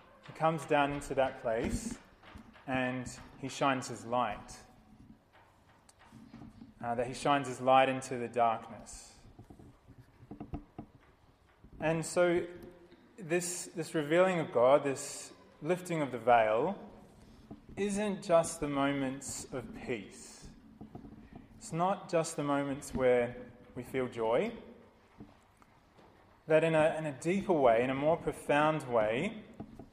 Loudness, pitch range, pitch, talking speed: -32 LUFS, 120-160 Hz, 140 Hz, 120 wpm